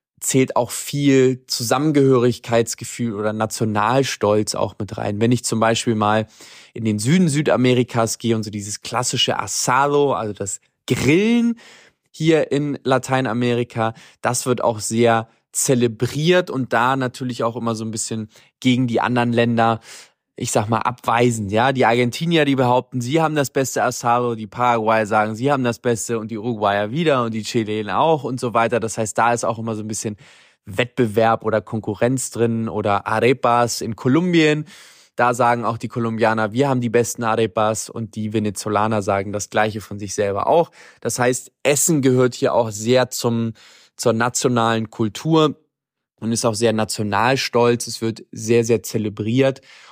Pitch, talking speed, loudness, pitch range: 120 Hz, 165 wpm, -19 LUFS, 110-130 Hz